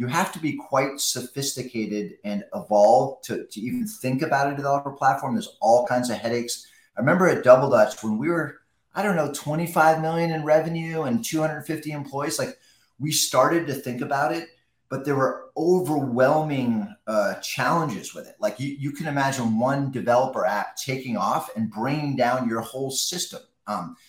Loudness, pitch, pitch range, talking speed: -24 LUFS, 140 Hz, 130-165 Hz, 175 wpm